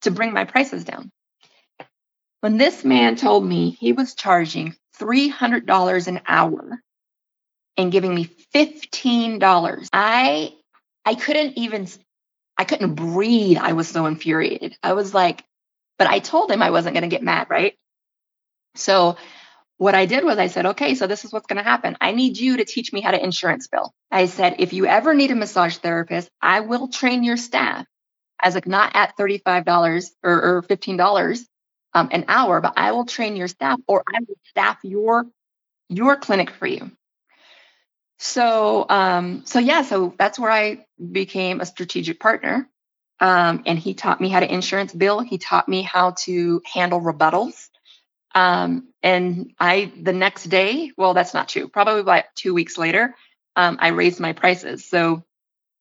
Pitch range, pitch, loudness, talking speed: 175-235 Hz, 190 Hz, -19 LUFS, 175 wpm